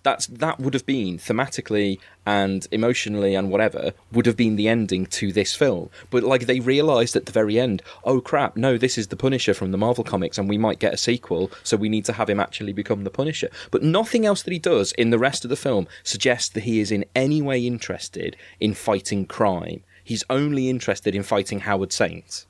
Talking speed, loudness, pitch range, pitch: 220 wpm, -22 LUFS, 100-130 Hz, 115 Hz